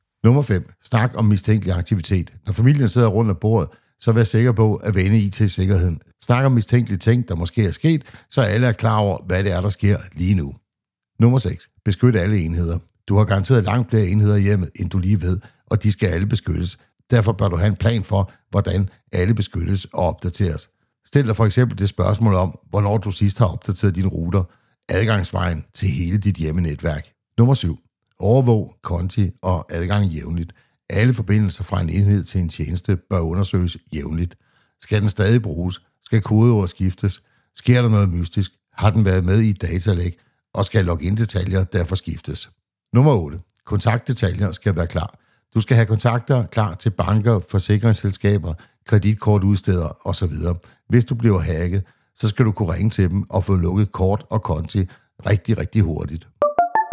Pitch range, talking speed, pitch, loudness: 90-115 Hz, 180 wpm, 100 Hz, -19 LUFS